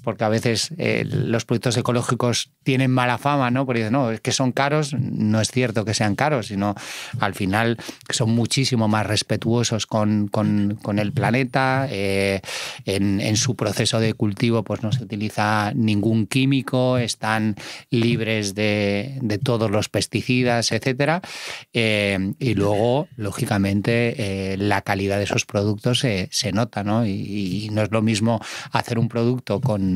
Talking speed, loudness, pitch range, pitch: 160 wpm, -21 LUFS, 105-125 Hz, 115 Hz